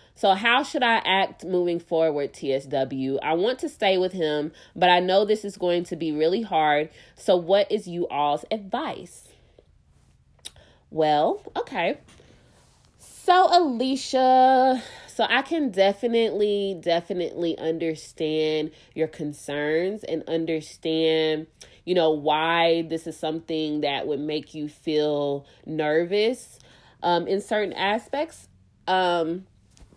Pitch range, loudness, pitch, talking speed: 150-200 Hz, -24 LUFS, 165 Hz, 120 wpm